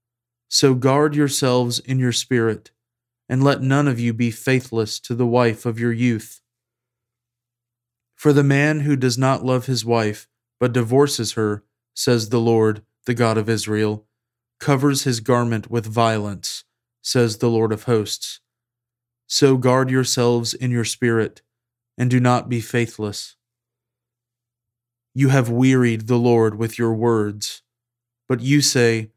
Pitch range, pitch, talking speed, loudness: 115-125 Hz, 120 Hz, 145 wpm, -19 LUFS